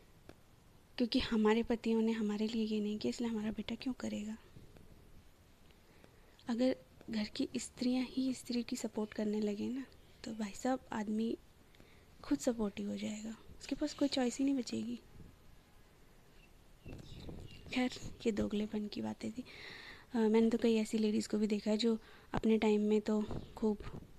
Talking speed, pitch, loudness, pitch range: 155 wpm, 225 Hz, -37 LUFS, 215-250 Hz